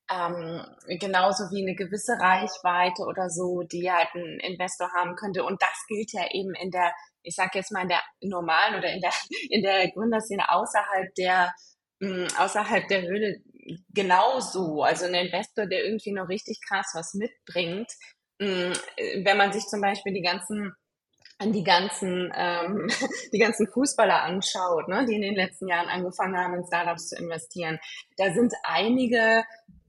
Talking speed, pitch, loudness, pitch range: 165 wpm, 190 Hz, -26 LUFS, 180-210 Hz